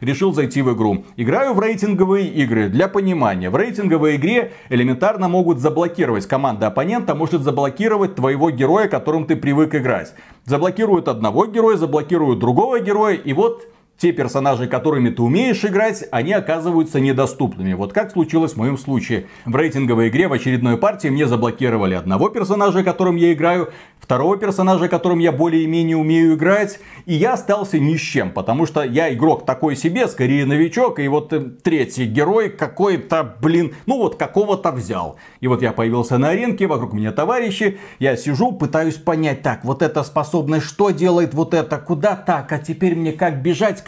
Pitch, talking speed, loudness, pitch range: 160 Hz, 165 wpm, -17 LUFS, 135-190 Hz